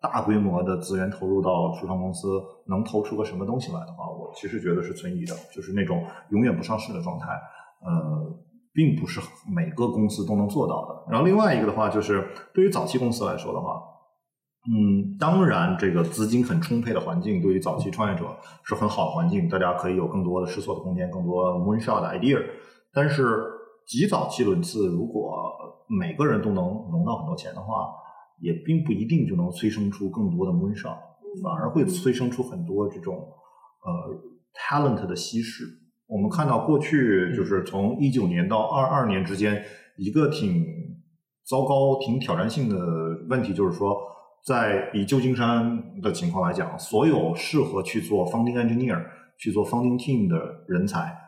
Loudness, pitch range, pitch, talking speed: -25 LUFS, 105-175 Hz, 130 Hz, 325 characters per minute